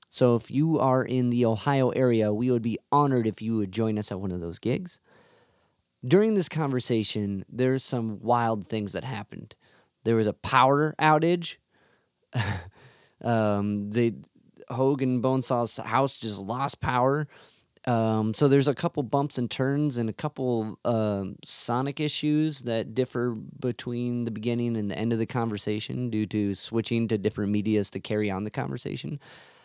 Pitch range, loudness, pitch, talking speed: 110-130 Hz, -27 LUFS, 120 Hz, 160 wpm